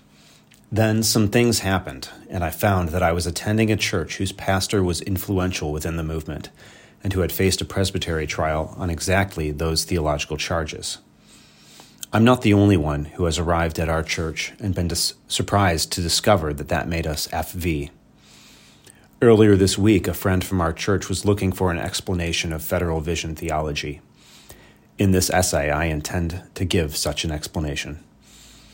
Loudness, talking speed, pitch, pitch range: -22 LUFS, 170 wpm, 90 Hz, 80-95 Hz